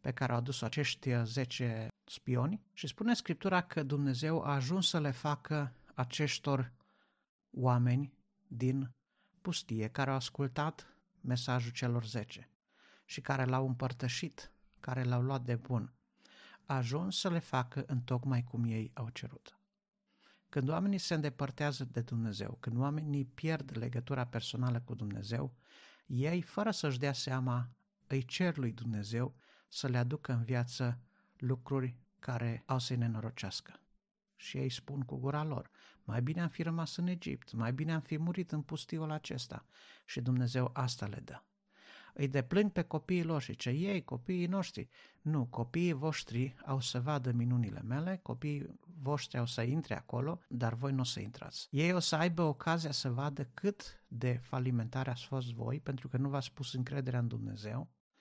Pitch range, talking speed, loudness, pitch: 125-155 Hz, 160 wpm, -37 LUFS, 135 Hz